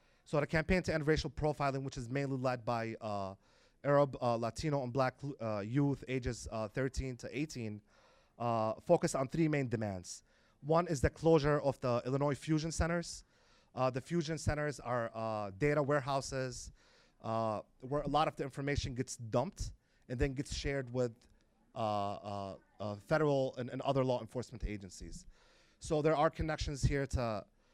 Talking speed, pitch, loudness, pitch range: 170 wpm, 130 Hz, -36 LUFS, 115-145 Hz